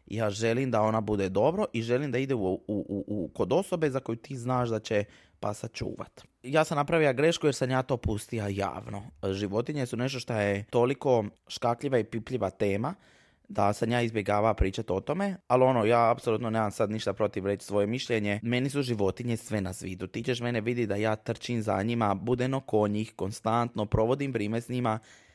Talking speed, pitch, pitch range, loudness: 200 wpm, 115 Hz, 105-125 Hz, -29 LUFS